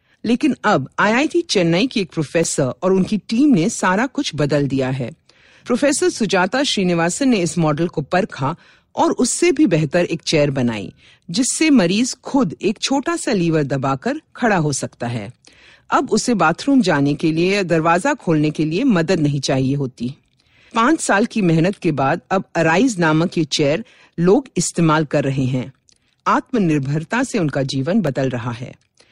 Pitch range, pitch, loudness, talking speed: 145-235 Hz, 170 Hz, -18 LUFS, 165 wpm